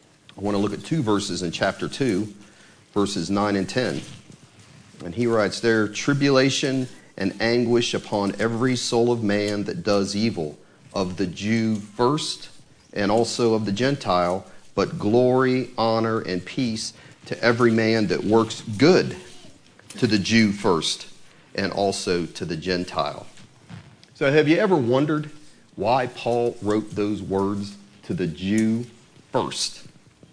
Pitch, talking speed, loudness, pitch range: 110 Hz, 140 wpm, -23 LUFS, 100-120 Hz